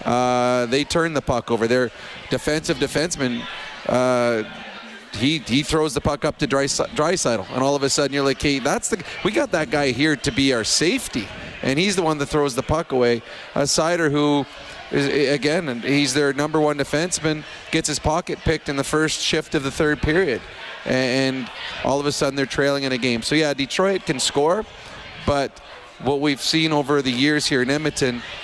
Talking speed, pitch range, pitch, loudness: 200 wpm, 135-155 Hz, 145 Hz, -21 LUFS